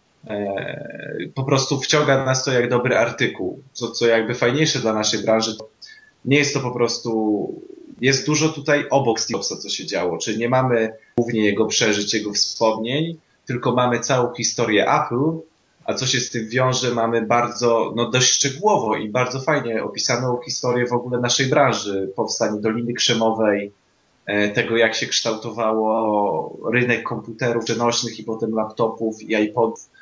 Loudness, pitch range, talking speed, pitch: -20 LUFS, 110-130 Hz, 155 wpm, 120 Hz